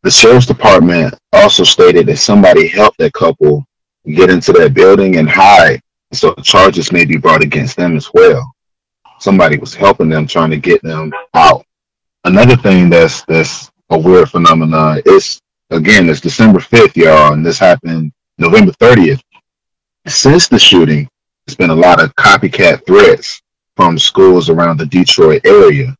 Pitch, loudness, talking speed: 100 Hz, -7 LUFS, 160 wpm